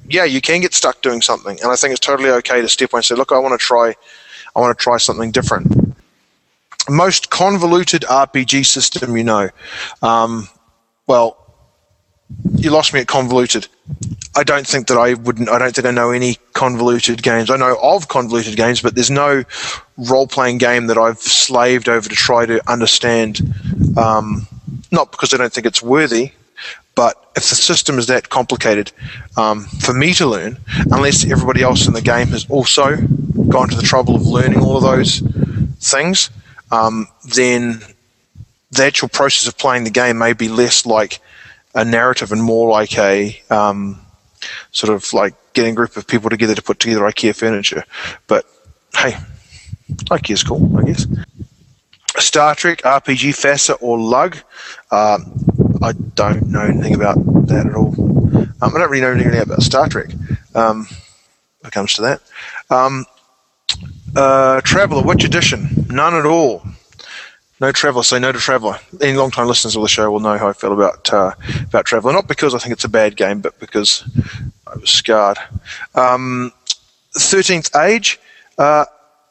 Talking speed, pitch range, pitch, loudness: 175 wpm, 110-135 Hz, 120 Hz, -14 LUFS